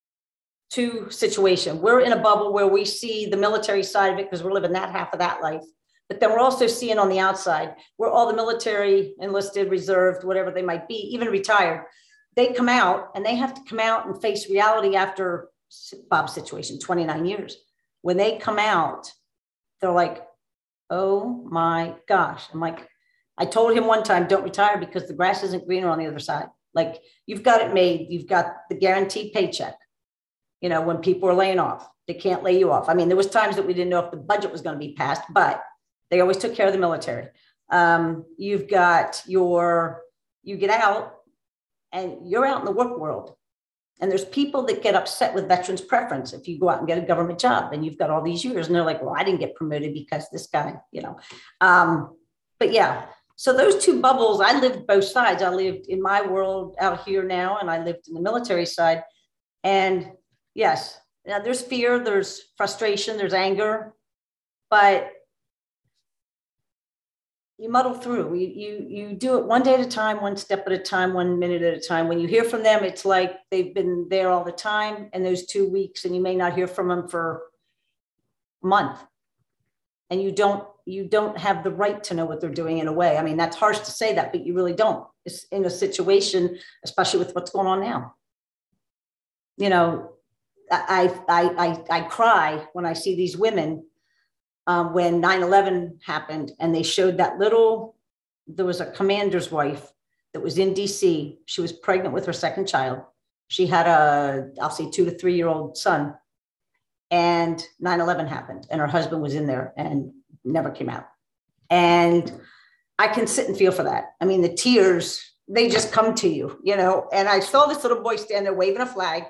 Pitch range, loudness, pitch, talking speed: 170-210 Hz, -22 LUFS, 190 Hz, 200 wpm